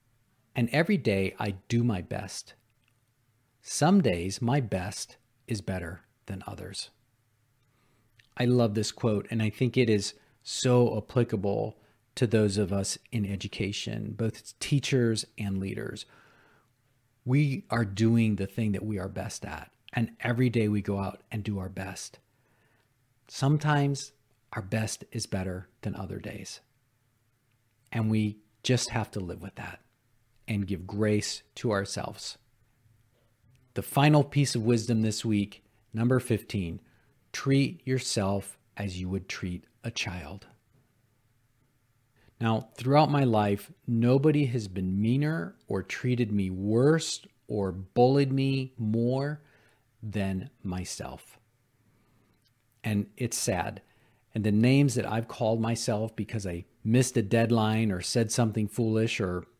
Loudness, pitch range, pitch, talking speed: -29 LUFS, 105-125 Hz, 115 Hz, 135 wpm